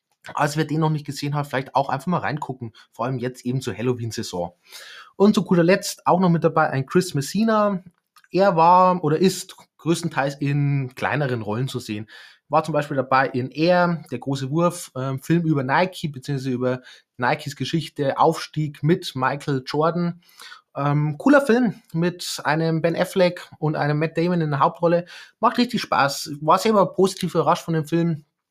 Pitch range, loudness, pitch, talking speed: 135-175 Hz, -22 LUFS, 155 Hz, 175 wpm